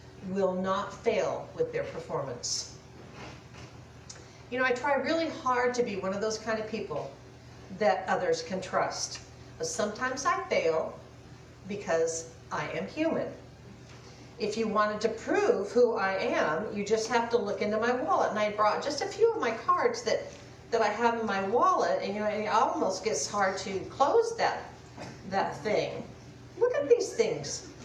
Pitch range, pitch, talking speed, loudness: 185-300 Hz, 215 Hz, 170 wpm, -29 LUFS